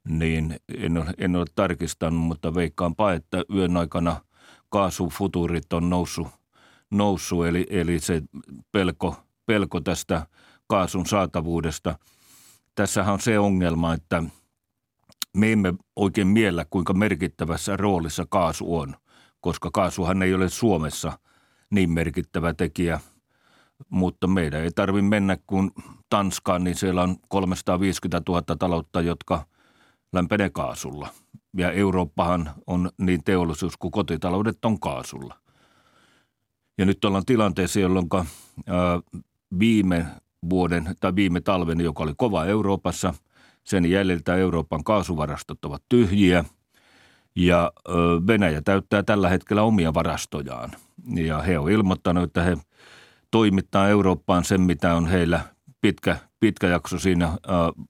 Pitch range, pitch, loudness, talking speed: 85-100 Hz, 90 Hz, -24 LUFS, 115 wpm